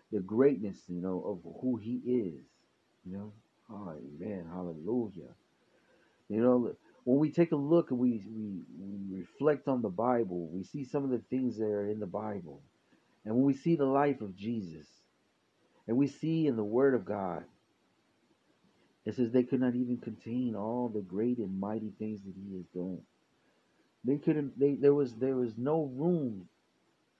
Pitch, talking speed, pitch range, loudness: 120 Hz, 180 wpm, 100-135 Hz, -33 LUFS